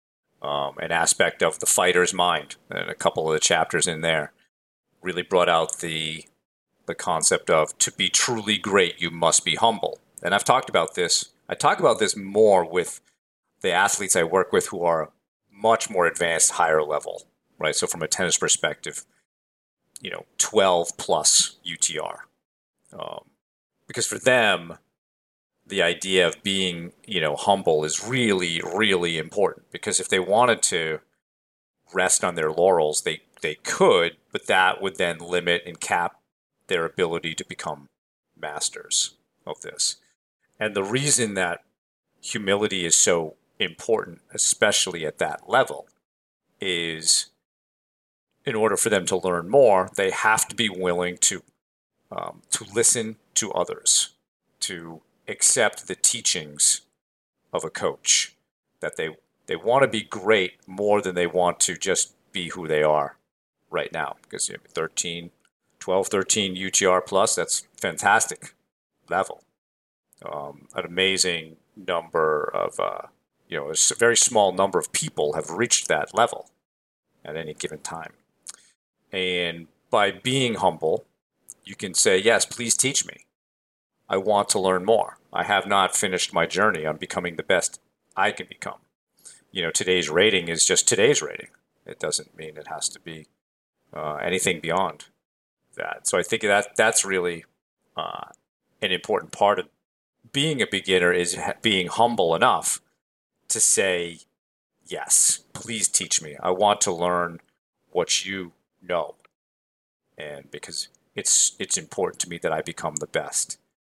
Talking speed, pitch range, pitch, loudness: 150 wpm, 80-100 Hz, 90 Hz, -22 LUFS